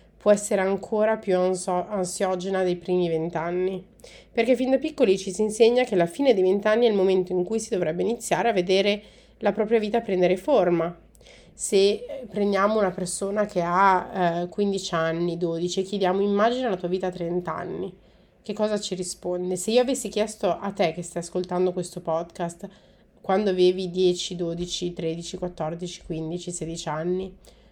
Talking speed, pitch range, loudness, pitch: 165 wpm, 175-205 Hz, -24 LUFS, 185 Hz